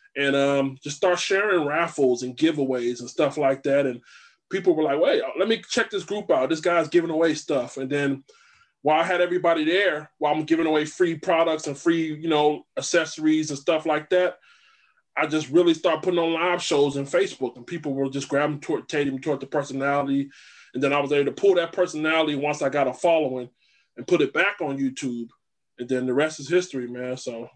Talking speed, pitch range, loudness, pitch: 215 wpm, 140-170 Hz, -23 LUFS, 150 Hz